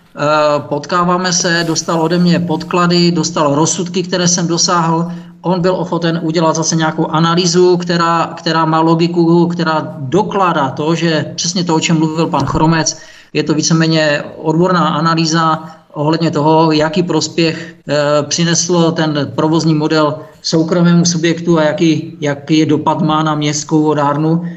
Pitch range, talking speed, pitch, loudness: 155-170 Hz, 140 wpm, 160 Hz, -13 LUFS